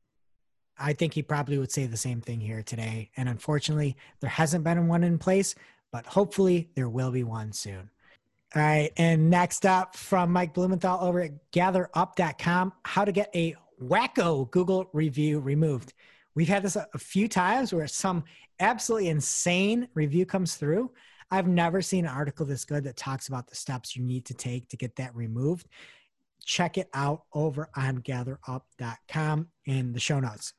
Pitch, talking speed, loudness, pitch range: 155 Hz, 175 wpm, -28 LUFS, 130-180 Hz